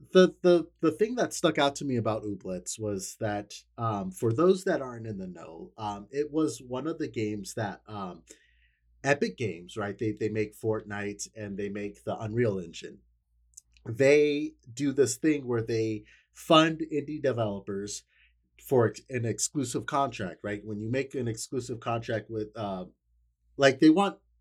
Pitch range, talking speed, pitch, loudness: 100-145 Hz, 170 wpm, 115 Hz, -29 LUFS